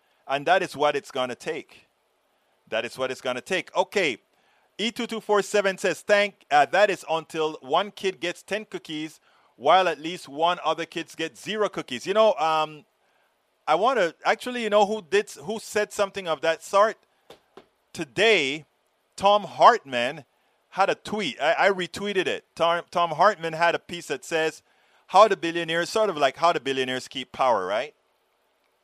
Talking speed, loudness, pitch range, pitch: 180 wpm, -24 LUFS, 155-205 Hz, 170 Hz